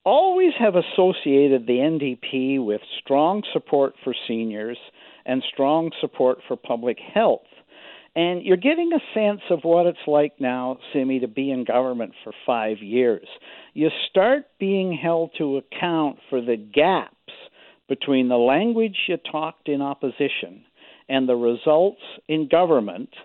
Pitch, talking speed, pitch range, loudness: 145 Hz, 140 wpm, 130-175 Hz, -22 LUFS